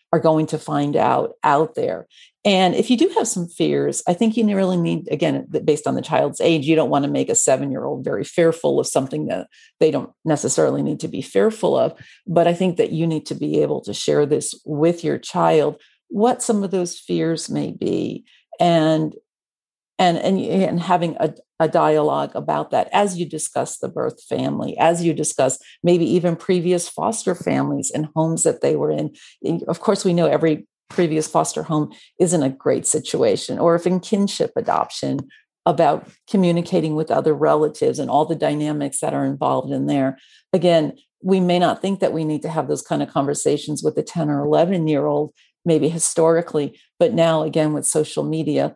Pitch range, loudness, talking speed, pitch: 155-185 Hz, -20 LUFS, 195 wpm, 165 Hz